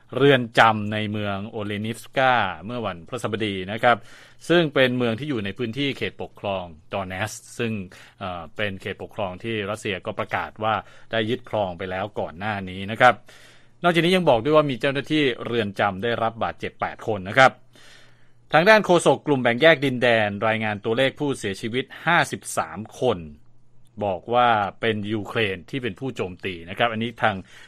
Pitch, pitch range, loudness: 115 Hz, 105-125 Hz, -23 LUFS